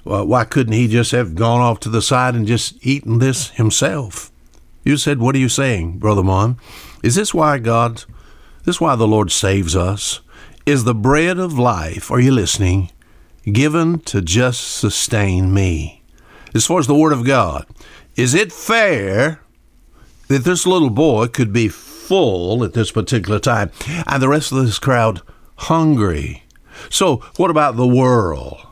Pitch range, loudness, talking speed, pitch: 105-140 Hz, -16 LUFS, 165 wpm, 120 Hz